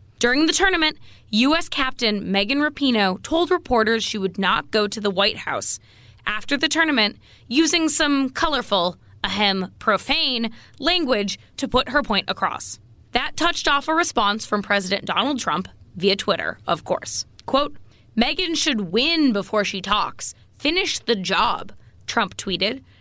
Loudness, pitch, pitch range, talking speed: -21 LUFS, 230 Hz, 200-295 Hz, 145 wpm